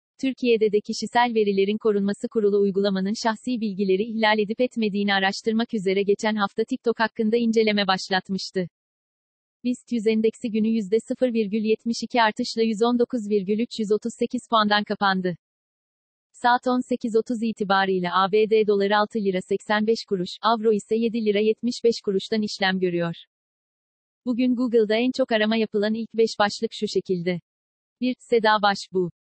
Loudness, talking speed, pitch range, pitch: -23 LUFS, 125 wpm, 205-230 Hz, 220 Hz